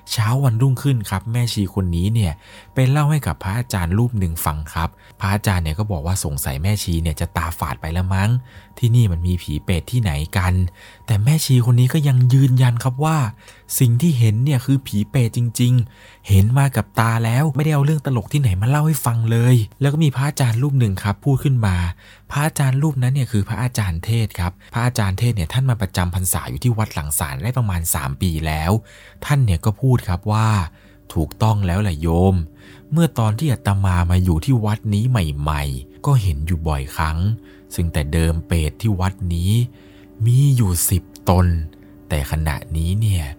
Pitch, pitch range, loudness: 105 Hz, 90-125 Hz, -19 LUFS